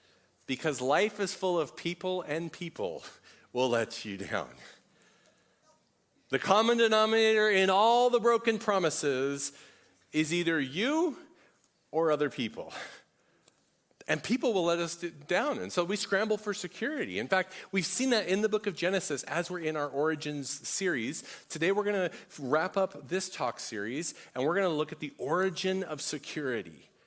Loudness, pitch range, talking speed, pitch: -30 LUFS, 155-205 Hz, 160 wpm, 180 Hz